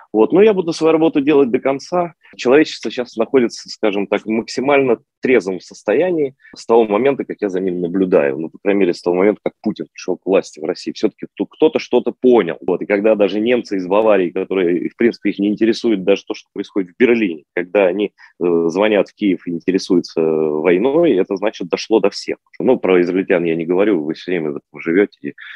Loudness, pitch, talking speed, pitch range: -17 LUFS, 110 Hz, 210 wpm, 95-130 Hz